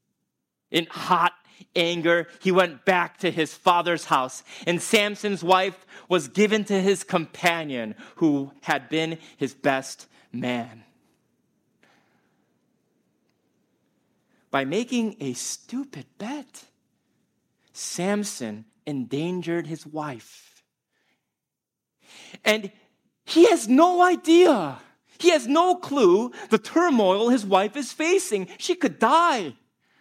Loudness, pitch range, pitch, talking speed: -23 LUFS, 160-235 Hz, 185 Hz, 100 wpm